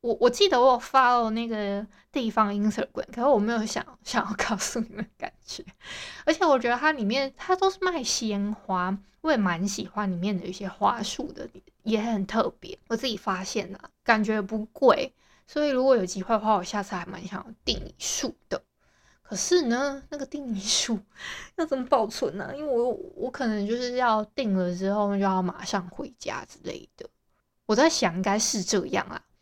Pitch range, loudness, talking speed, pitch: 200-265 Hz, -26 LUFS, 290 characters per minute, 225 Hz